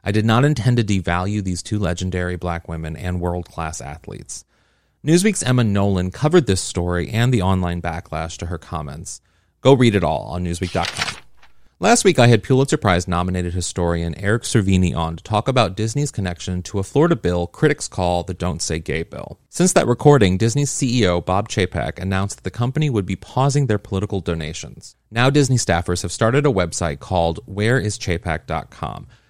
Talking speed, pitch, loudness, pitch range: 180 wpm, 95 Hz, -19 LUFS, 90-120 Hz